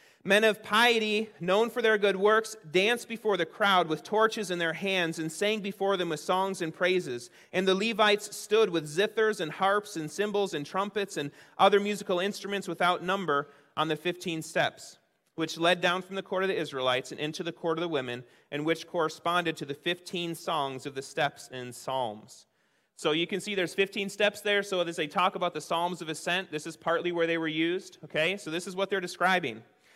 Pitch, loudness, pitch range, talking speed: 180 Hz, -29 LUFS, 160-200 Hz, 210 wpm